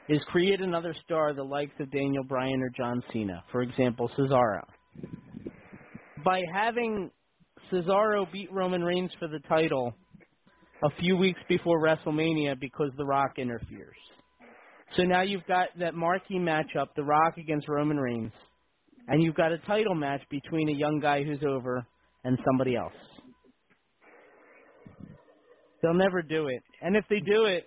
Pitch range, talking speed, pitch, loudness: 140-180 Hz, 150 wpm, 155 Hz, -29 LUFS